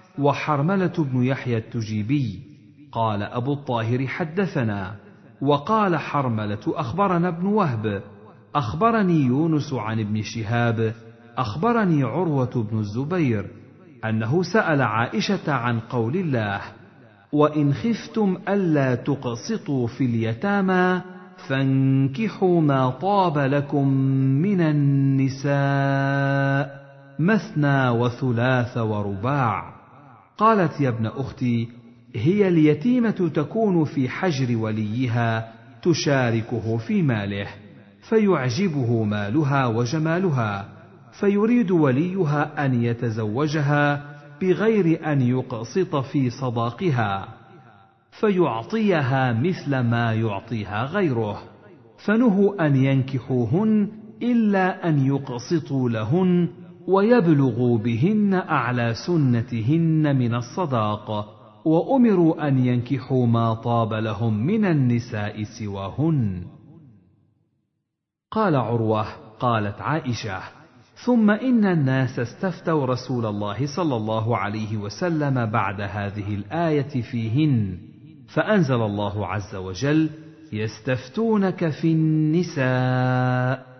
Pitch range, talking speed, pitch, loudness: 115-165 Hz, 85 wpm, 135 Hz, -22 LUFS